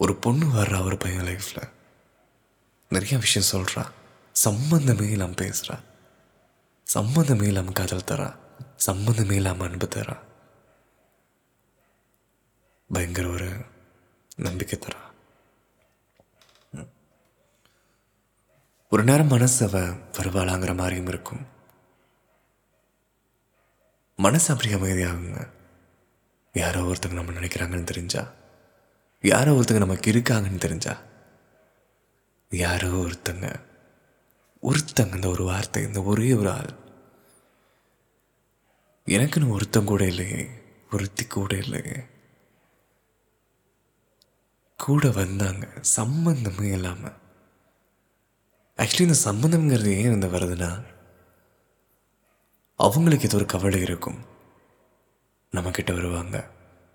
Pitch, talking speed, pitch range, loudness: 100 Hz, 85 wpm, 90-120 Hz, -24 LUFS